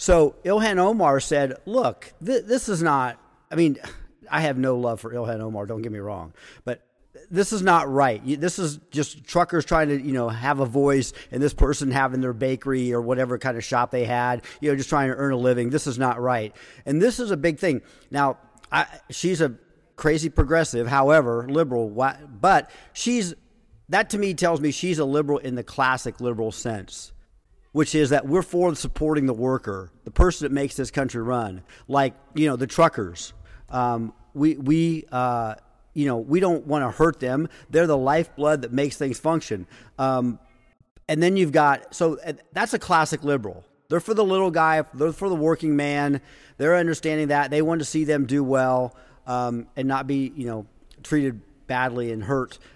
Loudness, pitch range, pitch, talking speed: -23 LUFS, 125-160 Hz, 140 Hz, 195 wpm